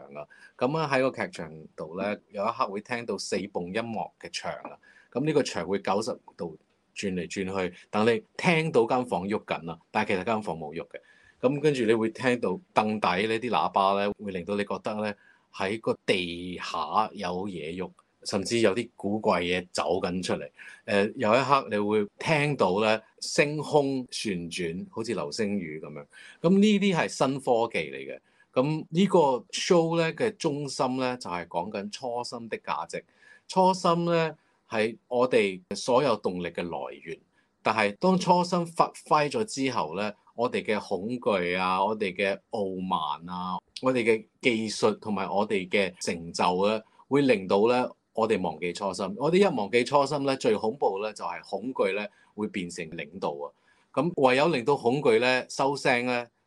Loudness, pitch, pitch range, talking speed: -27 LUFS, 115 Hz, 100-145 Hz, 250 characters per minute